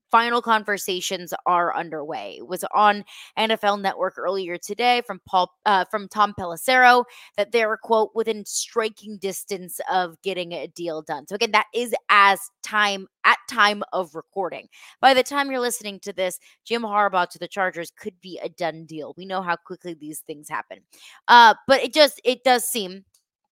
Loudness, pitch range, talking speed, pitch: -21 LUFS, 180-225 Hz, 180 wpm, 200 Hz